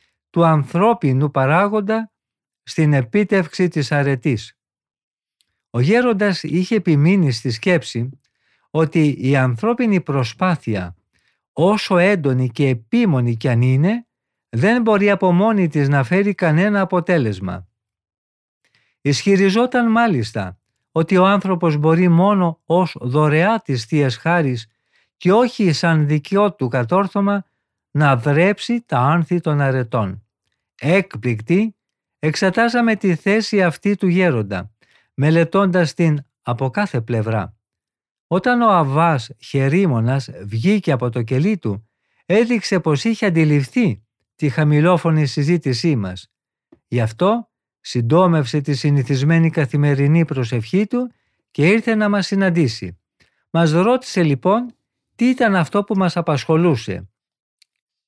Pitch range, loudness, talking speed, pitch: 130-195 Hz, -17 LUFS, 110 wpm, 160 Hz